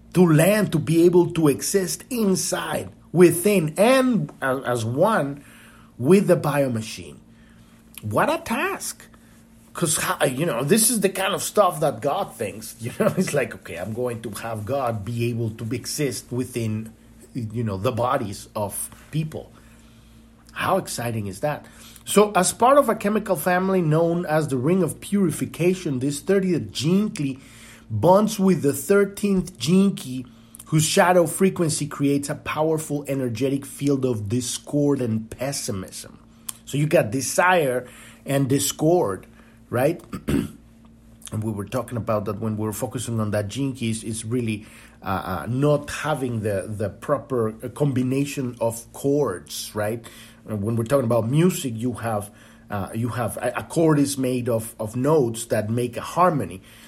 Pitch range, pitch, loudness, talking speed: 115-165 Hz, 130 Hz, -22 LUFS, 155 wpm